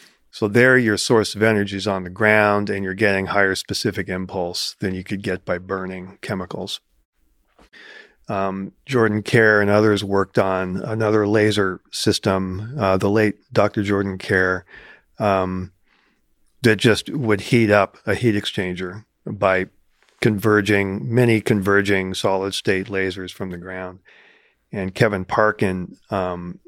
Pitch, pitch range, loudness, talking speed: 100 Hz, 95-105 Hz, -20 LUFS, 140 wpm